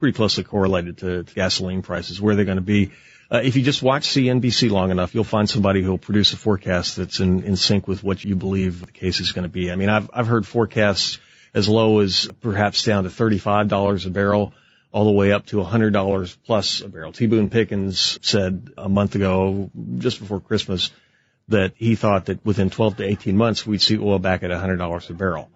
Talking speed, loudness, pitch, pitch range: 215 wpm, -20 LUFS, 100 Hz, 95-110 Hz